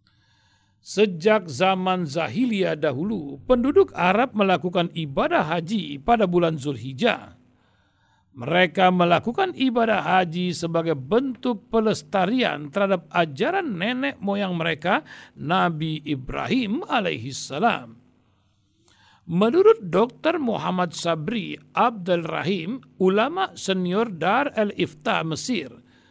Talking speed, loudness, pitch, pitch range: 85 wpm, -23 LUFS, 185 Hz, 155-220 Hz